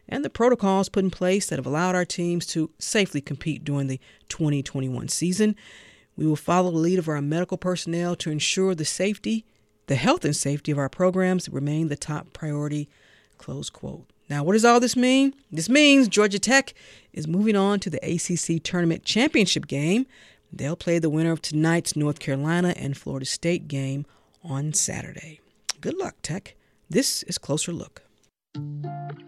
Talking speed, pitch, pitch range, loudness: 170 wpm, 165 Hz, 145-185 Hz, -24 LUFS